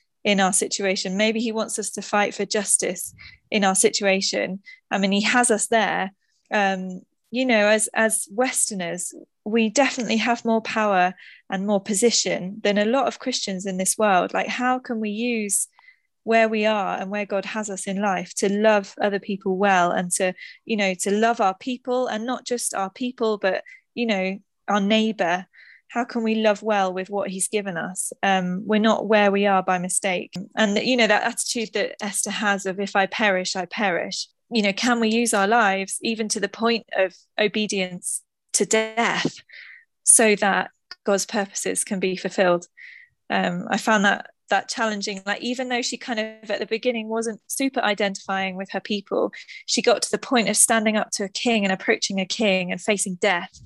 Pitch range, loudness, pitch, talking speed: 195-230 Hz, -22 LUFS, 210 Hz, 195 wpm